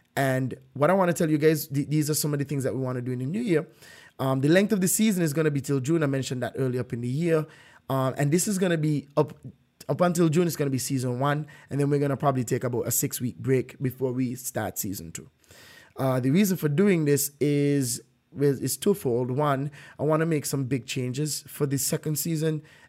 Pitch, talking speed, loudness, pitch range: 140 Hz, 245 wpm, -26 LUFS, 130-155 Hz